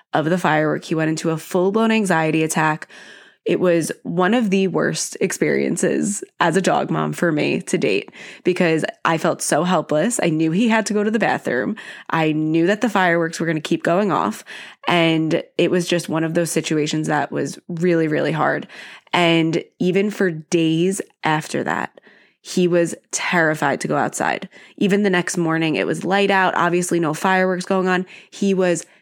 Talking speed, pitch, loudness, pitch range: 185 wpm, 170 Hz, -19 LUFS, 160-185 Hz